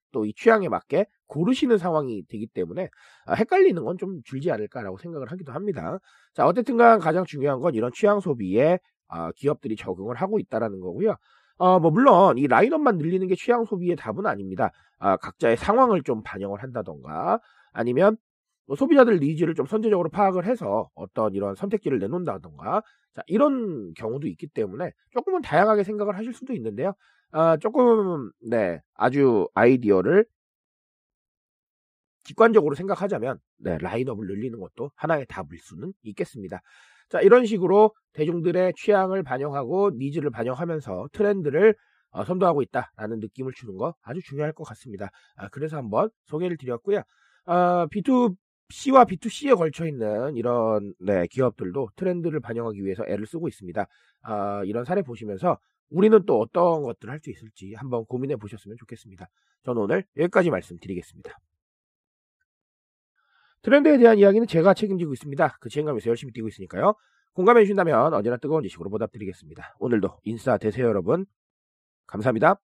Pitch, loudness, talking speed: 165 Hz, -23 LUFS, 380 characters per minute